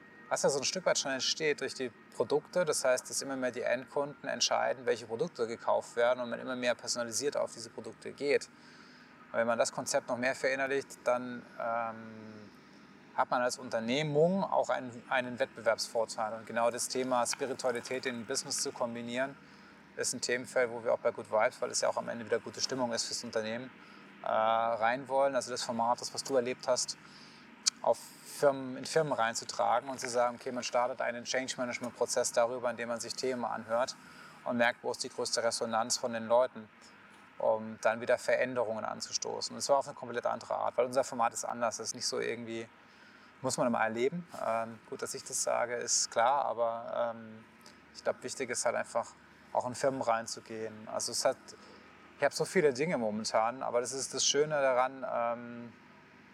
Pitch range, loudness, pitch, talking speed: 115-135 Hz, -33 LUFS, 125 Hz, 195 wpm